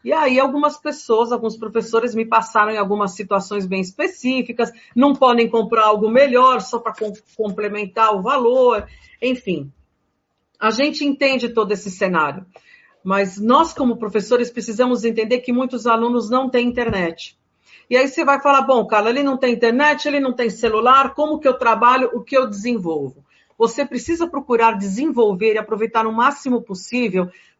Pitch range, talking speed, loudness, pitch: 215-260 Hz, 160 wpm, -18 LUFS, 235 Hz